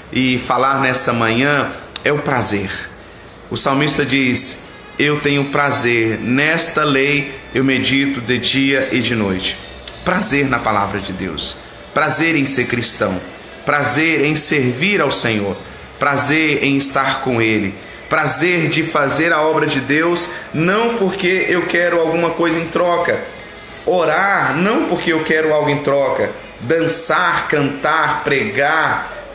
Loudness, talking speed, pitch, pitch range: -15 LUFS, 135 wpm, 140 Hz, 125-160 Hz